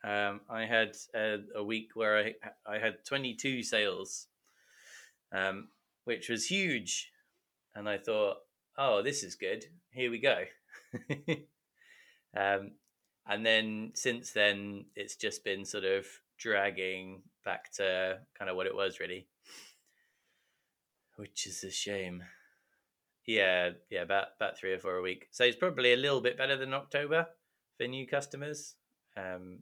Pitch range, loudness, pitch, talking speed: 100-145 Hz, -33 LUFS, 115 Hz, 145 wpm